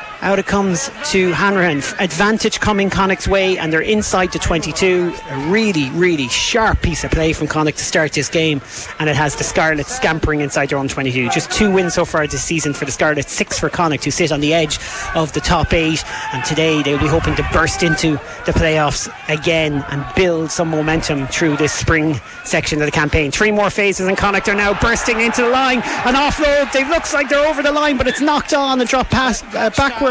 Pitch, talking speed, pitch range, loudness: 170 Hz, 220 wpm, 155-210 Hz, -16 LUFS